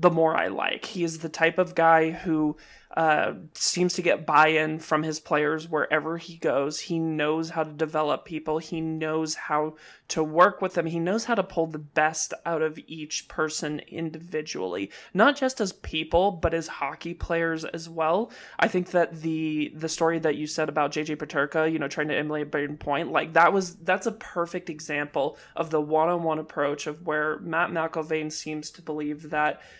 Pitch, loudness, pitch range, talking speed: 160 Hz, -26 LUFS, 155-170 Hz, 190 wpm